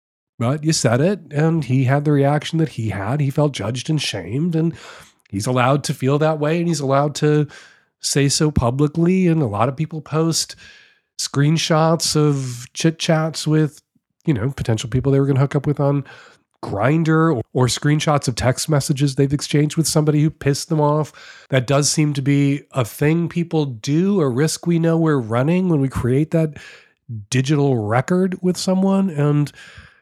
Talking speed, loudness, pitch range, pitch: 185 wpm, -19 LUFS, 135-160 Hz, 150 Hz